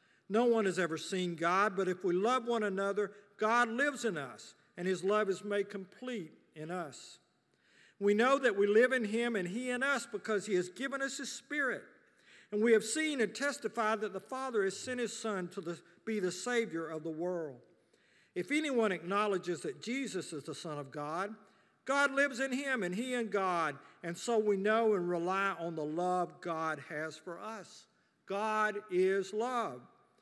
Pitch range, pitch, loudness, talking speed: 180-235 Hz, 205 Hz, -34 LUFS, 195 wpm